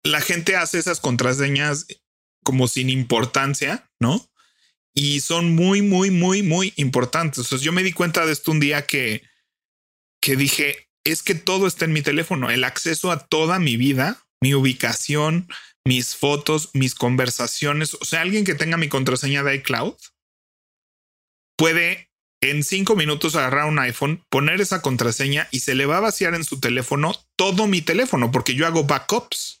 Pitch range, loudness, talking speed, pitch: 130-170 Hz, -20 LUFS, 170 wpm, 145 Hz